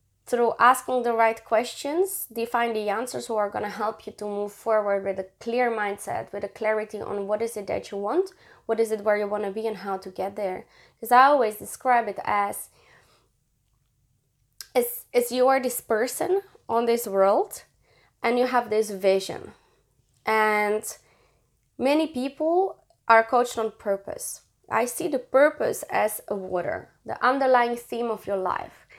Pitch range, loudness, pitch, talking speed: 200-245 Hz, -25 LUFS, 220 Hz, 170 wpm